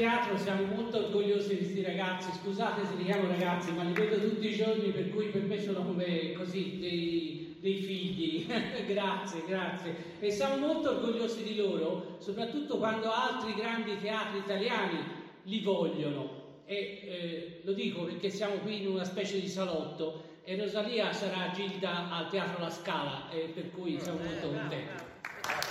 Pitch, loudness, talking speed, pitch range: 195 Hz, -34 LUFS, 165 wpm, 175-210 Hz